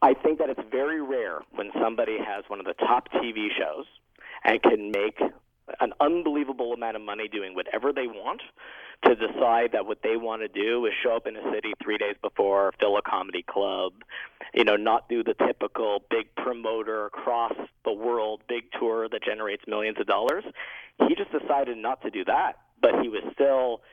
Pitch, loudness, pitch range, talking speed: 115 Hz, -27 LUFS, 110-130 Hz, 195 wpm